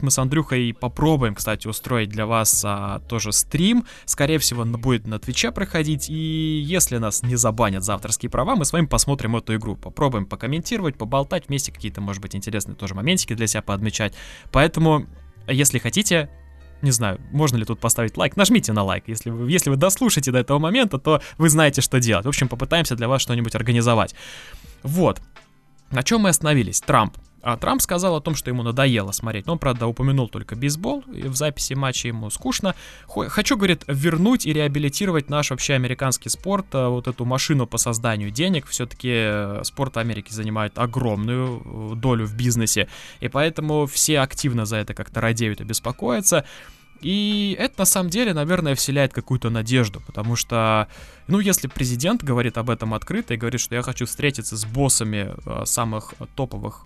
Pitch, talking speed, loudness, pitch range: 125 Hz, 175 wpm, -21 LUFS, 110-150 Hz